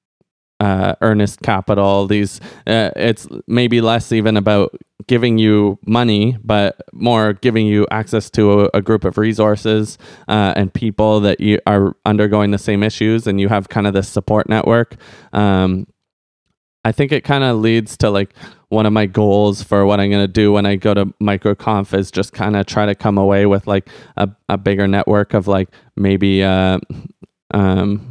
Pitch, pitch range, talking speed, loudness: 105 Hz, 100-110 Hz, 180 wpm, -15 LUFS